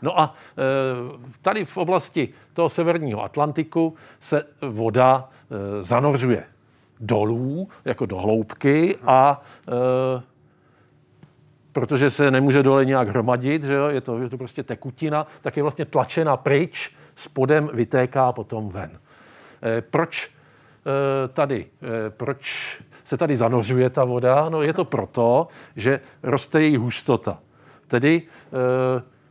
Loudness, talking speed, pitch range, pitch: -22 LUFS, 130 wpm, 125-150 Hz, 135 Hz